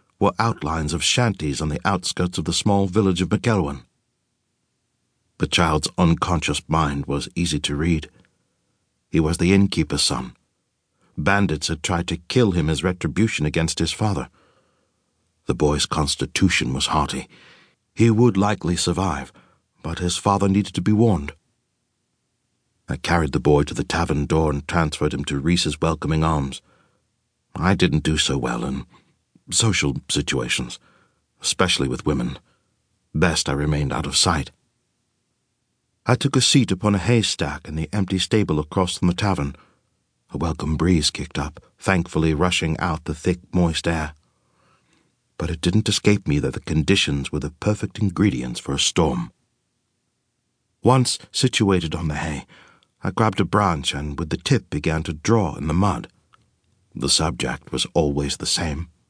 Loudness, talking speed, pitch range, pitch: -21 LUFS, 155 wpm, 75-100 Hz, 85 Hz